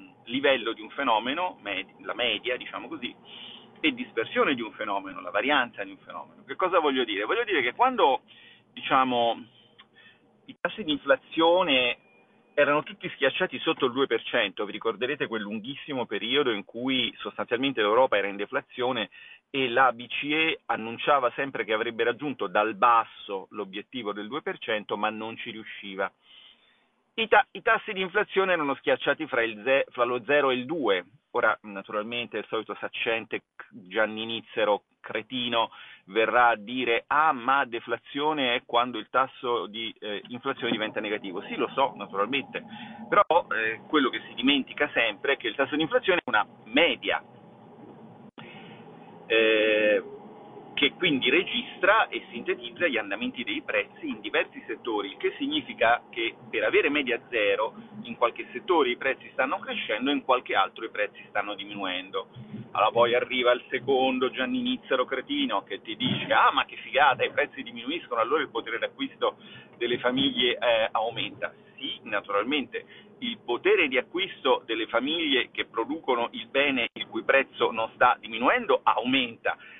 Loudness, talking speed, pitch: -26 LUFS, 155 wpm, 140 Hz